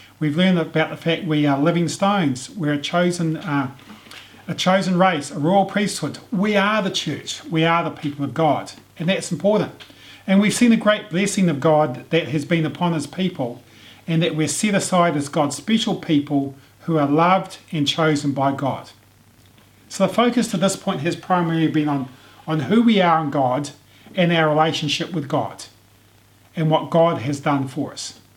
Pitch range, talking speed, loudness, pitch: 140-180 Hz, 190 wpm, -20 LUFS, 155 Hz